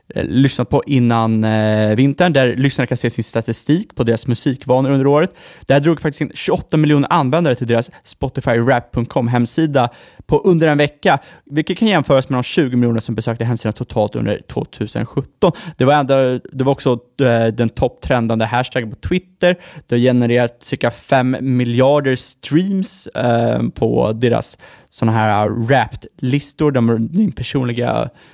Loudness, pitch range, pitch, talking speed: -16 LUFS, 120-145 Hz, 130 Hz, 150 wpm